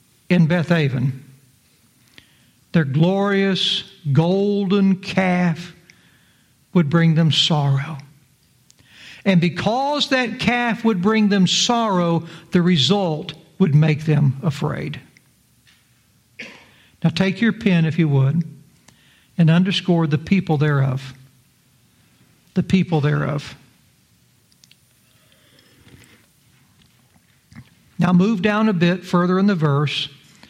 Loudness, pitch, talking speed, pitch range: -18 LUFS, 170 Hz, 95 wpm, 150-190 Hz